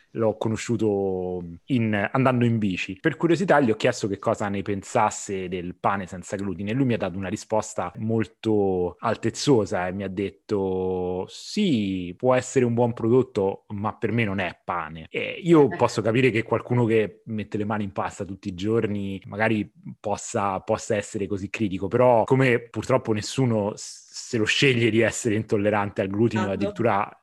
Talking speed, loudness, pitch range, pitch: 170 wpm, -24 LUFS, 100-115 Hz, 105 Hz